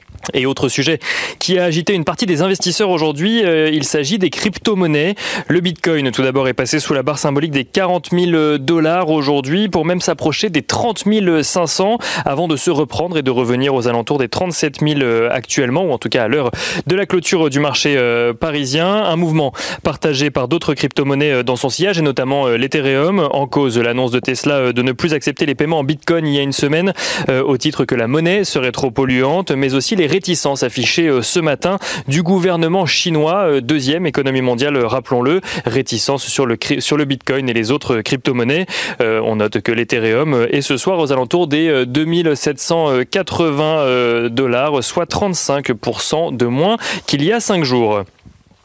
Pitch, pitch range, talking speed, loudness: 150 Hz, 130-175 Hz, 185 wpm, -15 LUFS